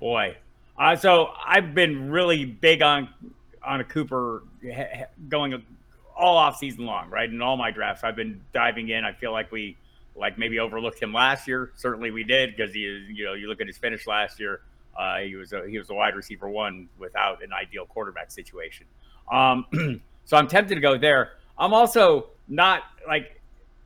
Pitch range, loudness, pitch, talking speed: 115-155 Hz, -23 LUFS, 130 Hz, 200 wpm